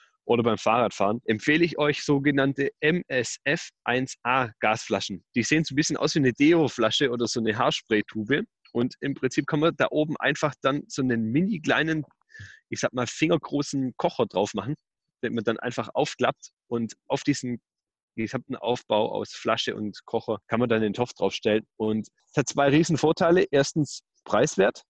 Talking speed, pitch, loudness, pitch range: 160 wpm, 135 Hz, -25 LUFS, 115-150 Hz